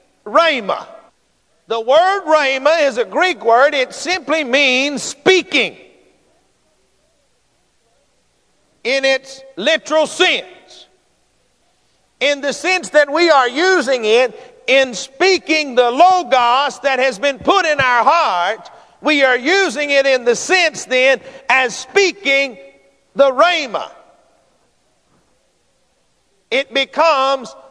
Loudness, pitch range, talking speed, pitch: -14 LUFS, 260-315 Hz, 105 wpm, 275 Hz